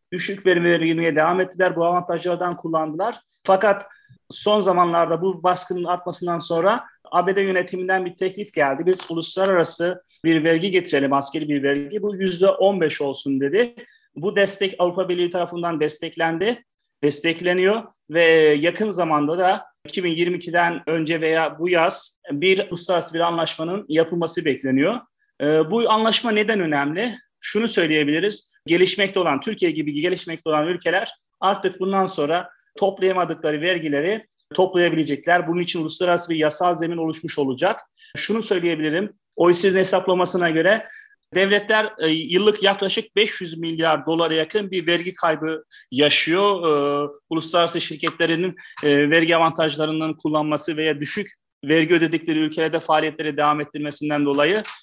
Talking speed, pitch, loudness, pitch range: 120 wpm, 175 Hz, -20 LUFS, 160-190 Hz